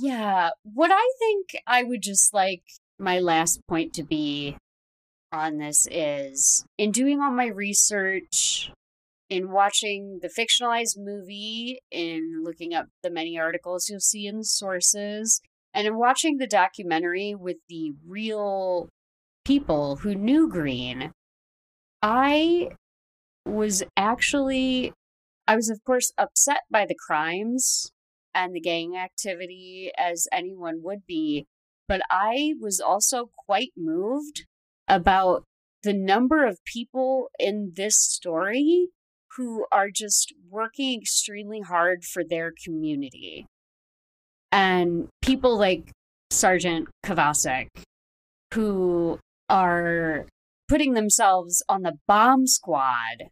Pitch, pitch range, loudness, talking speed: 195 Hz, 165-230 Hz, -23 LUFS, 115 wpm